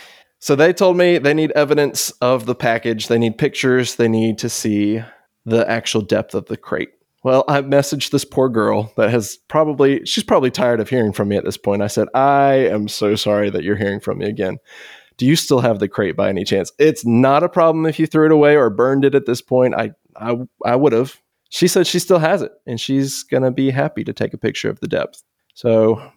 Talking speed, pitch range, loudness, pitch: 235 wpm, 115-150 Hz, -17 LUFS, 130 Hz